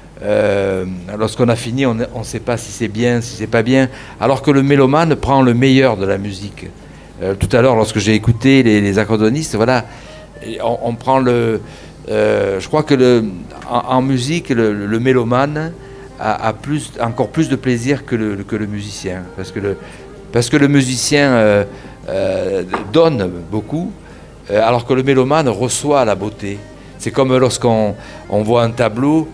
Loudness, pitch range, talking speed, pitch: -15 LUFS, 105-135 Hz, 180 wpm, 120 Hz